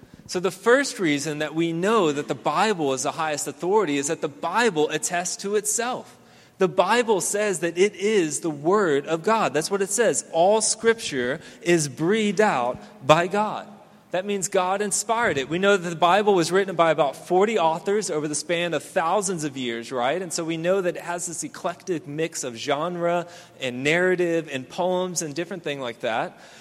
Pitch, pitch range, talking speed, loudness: 175 Hz, 155-200 Hz, 195 wpm, -23 LUFS